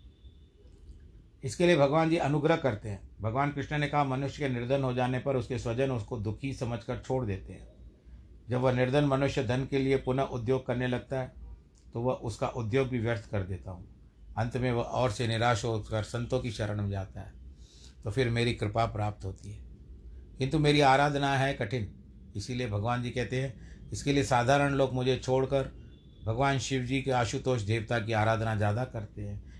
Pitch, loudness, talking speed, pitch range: 120 Hz, -30 LUFS, 190 wpm, 105-135 Hz